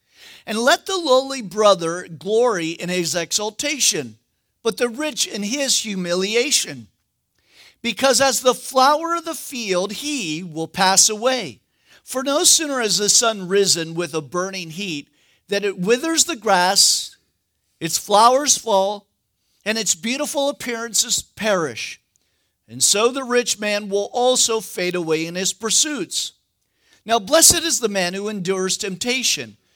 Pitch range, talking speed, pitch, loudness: 180-255 Hz, 140 wpm, 210 Hz, -18 LUFS